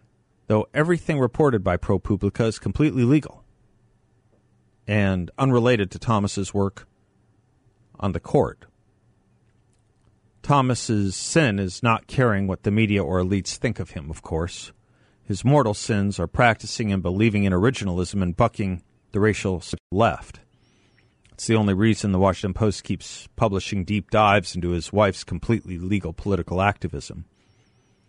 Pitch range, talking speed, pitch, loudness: 95-115 Hz, 135 wpm, 100 Hz, -23 LUFS